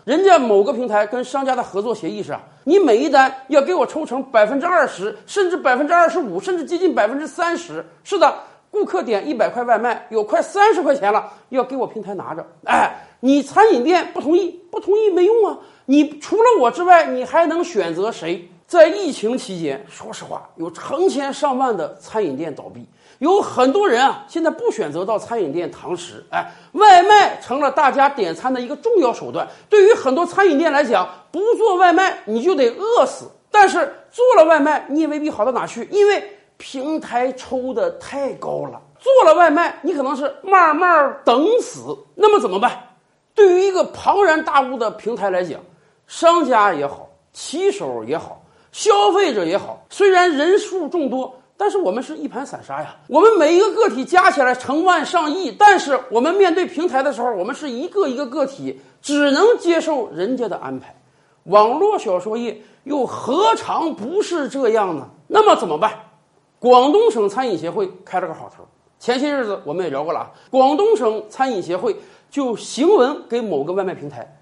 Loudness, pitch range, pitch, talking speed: -17 LUFS, 250-380 Hz, 305 Hz, 280 characters per minute